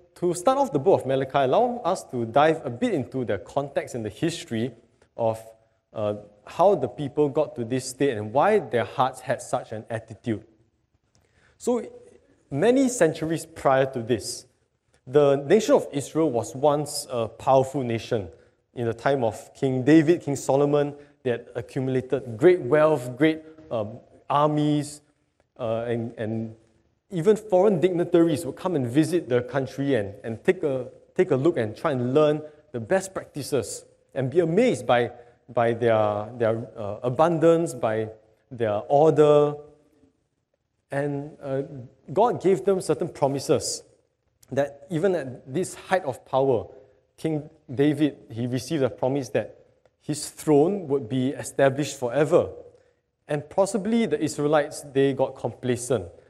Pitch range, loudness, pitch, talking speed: 120-160 Hz, -24 LUFS, 140 Hz, 150 wpm